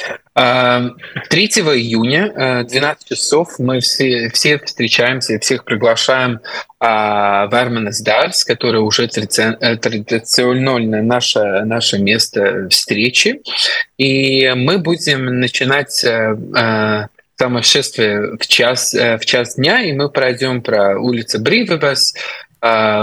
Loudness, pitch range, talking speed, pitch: -13 LUFS, 115-135 Hz, 95 wpm, 125 Hz